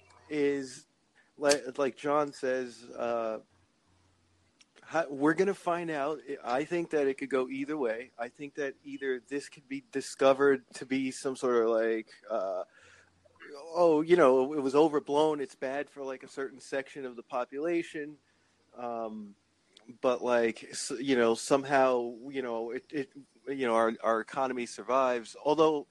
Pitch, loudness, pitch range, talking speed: 135 Hz, -31 LUFS, 120-145 Hz, 155 wpm